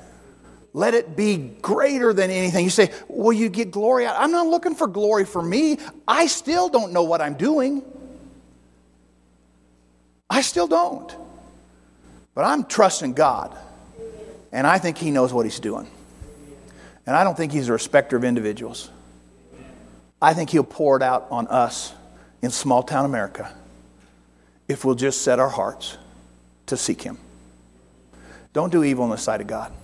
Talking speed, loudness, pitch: 160 wpm, -21 LUFS, 130 Hz